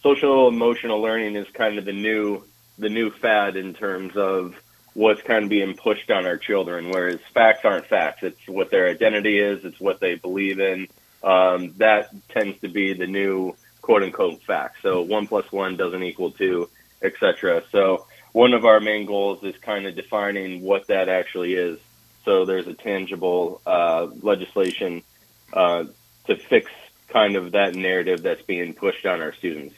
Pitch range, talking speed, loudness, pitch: 95-115 Hz, 175 wpm, -21 LUFS, 100 Hz